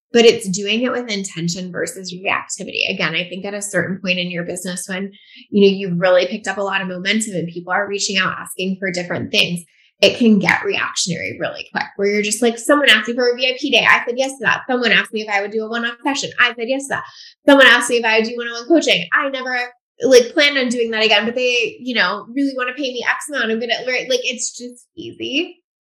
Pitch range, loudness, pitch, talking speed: 195-260 Hz, -17 LUFS, 230 Hz, 255 wpm